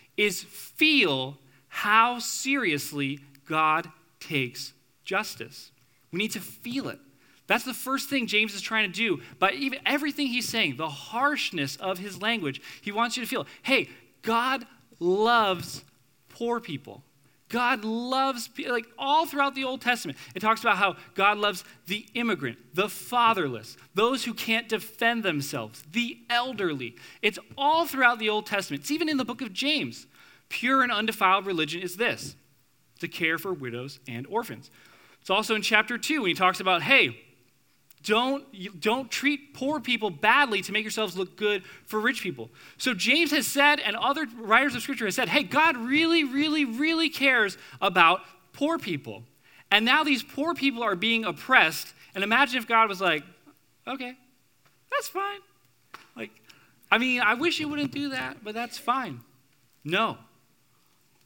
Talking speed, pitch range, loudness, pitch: 165 wpm, 170-260 Hz, -25 LUFS, 220 Hz